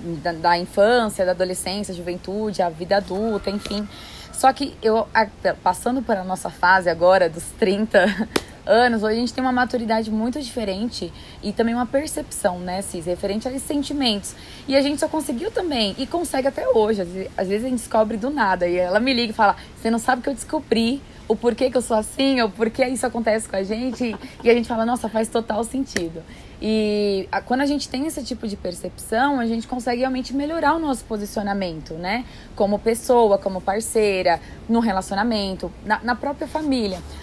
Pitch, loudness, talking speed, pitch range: 225 Hz, -22 LUFS, 190 wpm, 195-255 Hz